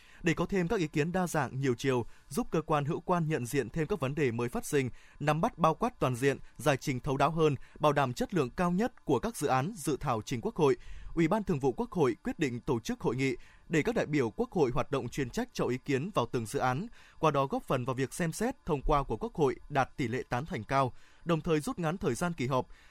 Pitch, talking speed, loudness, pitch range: 150 Hz, 280 wpm, -32 LUFS, 135-175 Hz